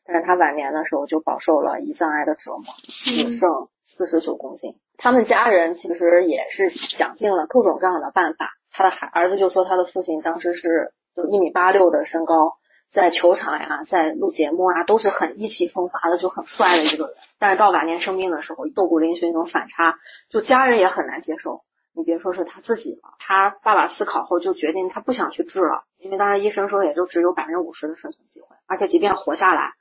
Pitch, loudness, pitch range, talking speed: 180 Hz, -20 LUFS, 165-210 Hz, 335 characters per minute